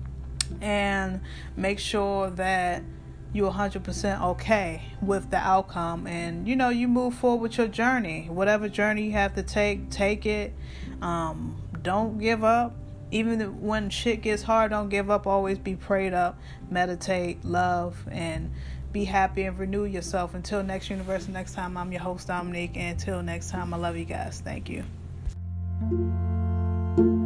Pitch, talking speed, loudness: 190 Hz, 155 wpm, -27 LUFS